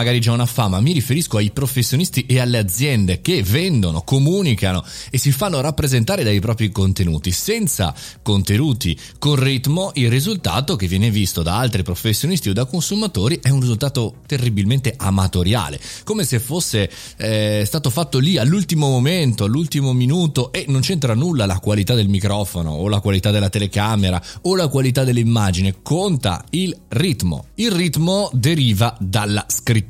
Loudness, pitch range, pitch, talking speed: -18 LUFS, 100-145 Hz, 120 Hz, 155 wpm